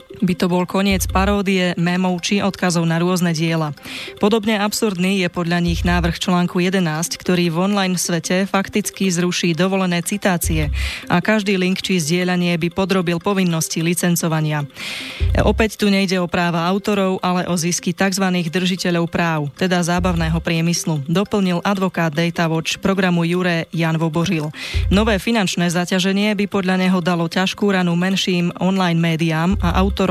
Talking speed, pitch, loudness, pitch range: 145 wpm, 180 Hz, -18 LUFS, 170-195 Hz